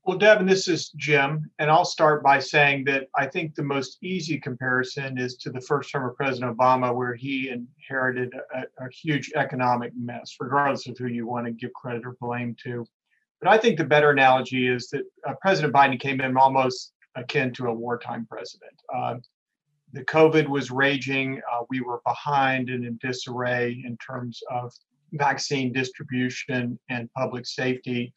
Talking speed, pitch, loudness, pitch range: 175 wpm, 130 Hz, -24 LUFS, 125-145 Hz